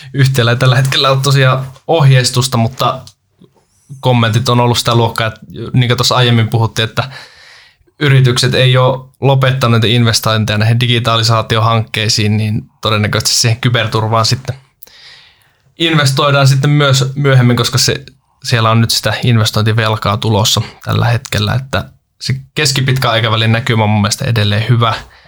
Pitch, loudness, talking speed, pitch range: 120 Hz, -11 LUFS, 130 wpm, 110-130 Hz